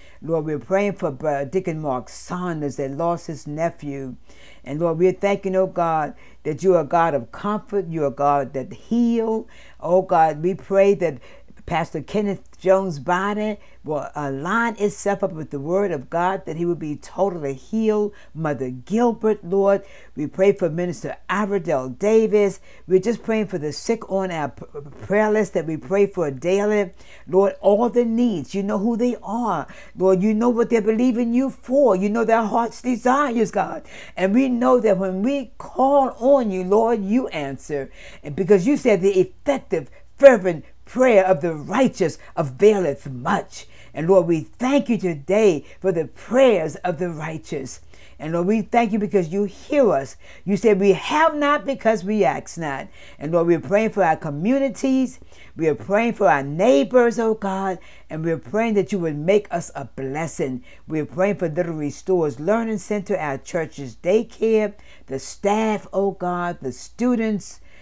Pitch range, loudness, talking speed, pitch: 160-215 Hz, -21 LUFS, 180 wpm, 190 Hz